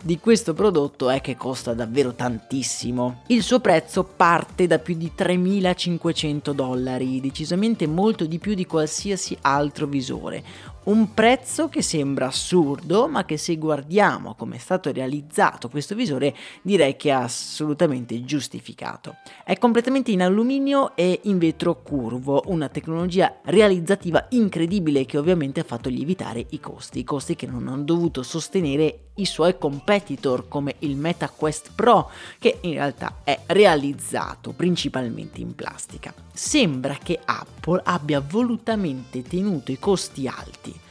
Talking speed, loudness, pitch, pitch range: 140 wpm, -22 LUFS, 160 Hz, 135-185 Hz